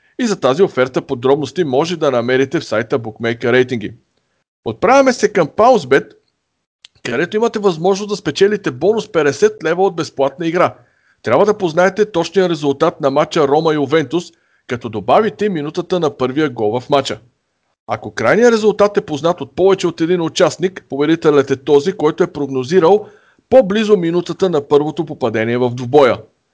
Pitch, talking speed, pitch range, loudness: 165 Hz, 155 wpm, 140-195 Hz, -15 LUFS